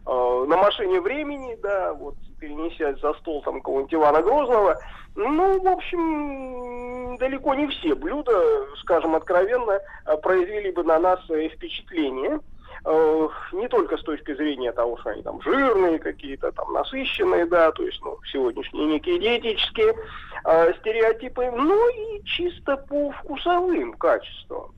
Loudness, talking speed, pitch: -23 LUFS, 135 wpm, 250 Hz